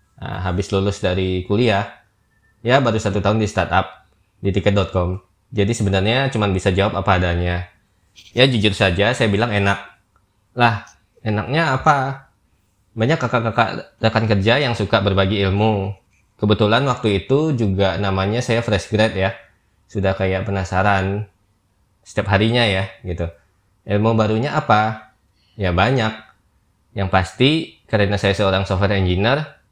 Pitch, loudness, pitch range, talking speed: 100 Hz, -18 LUFS, 95-110 Hz, 130 wpm